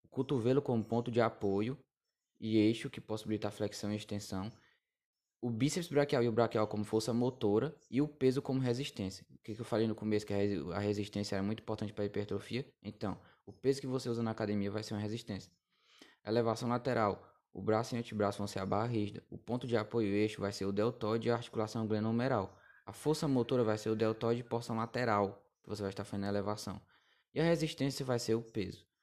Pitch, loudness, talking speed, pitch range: 110 Hz, -36 LUFS, 215 wpm, 105-120 Hz